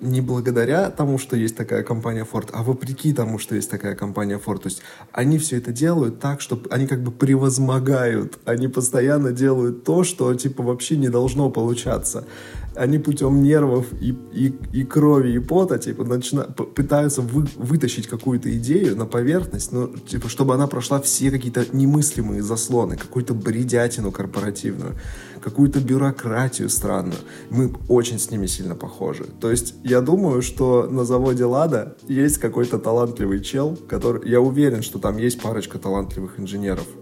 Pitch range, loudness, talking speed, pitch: 115-135 Hz, -21 LUFS, 160 wpm, 125 Hz